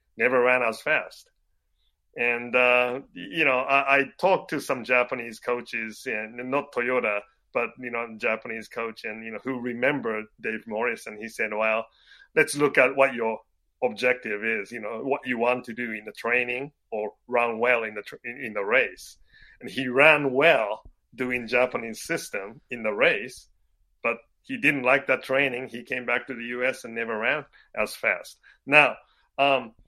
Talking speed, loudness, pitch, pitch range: 180 wpm, -25 LUFS, 120 Hz, 115-130 Hz